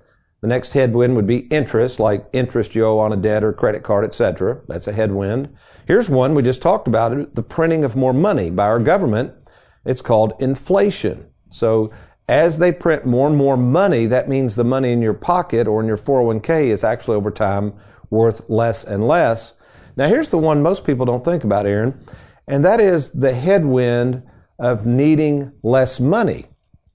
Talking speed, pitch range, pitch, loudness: 185 wpm, 110-140 Hz, 125 Hz, -17 LUFS